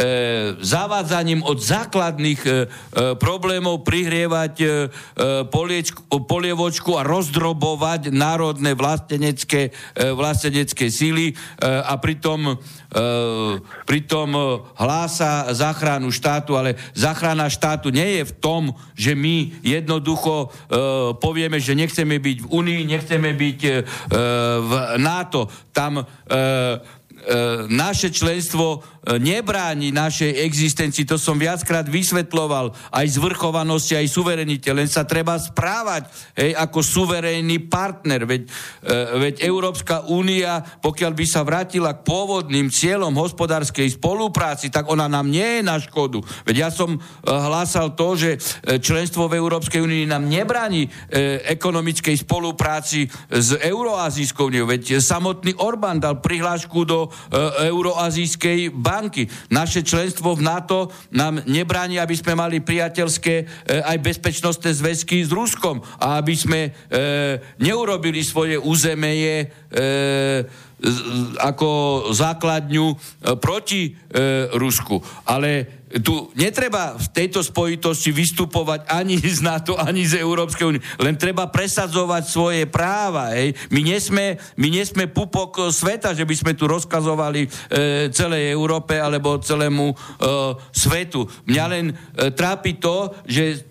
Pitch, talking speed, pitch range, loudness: 155 Hz, 120 wpm, 140-170 Hz, -20 LUFS